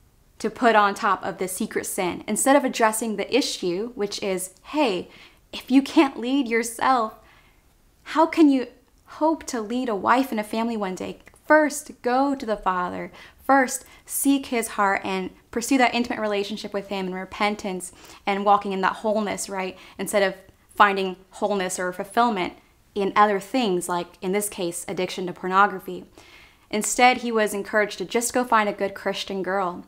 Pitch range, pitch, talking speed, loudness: 195-245 Hz, 210 Hz, 175 wpm, -23 LUFS